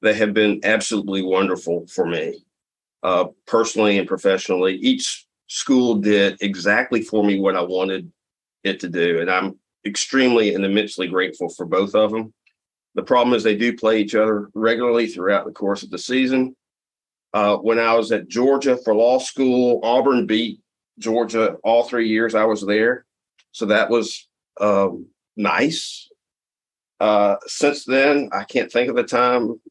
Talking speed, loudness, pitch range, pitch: 160 wpm, -19 LUFS, 105-120 Hz, 110 Hz